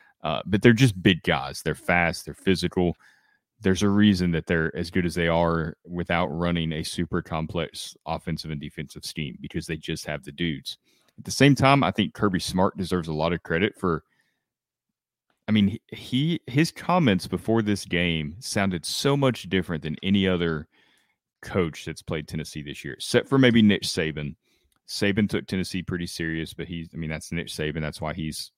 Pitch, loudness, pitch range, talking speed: 85 Hz, -25 LUFS, 80-100 Hz, 190 wpm